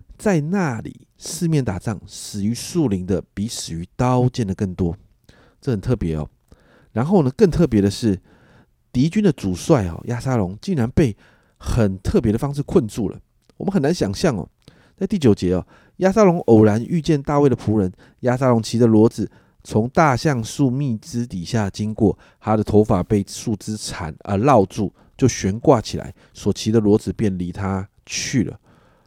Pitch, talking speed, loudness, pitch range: 110 Hz, 250 characters per minute, -20 LUFS, 100-130 Hz